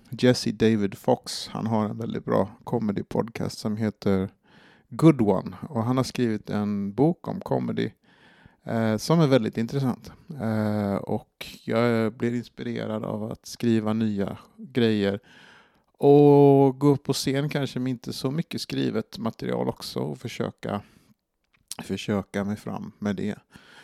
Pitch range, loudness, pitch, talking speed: 105-135 Hz, -25 LUFS, 115 Hz, 145 wpm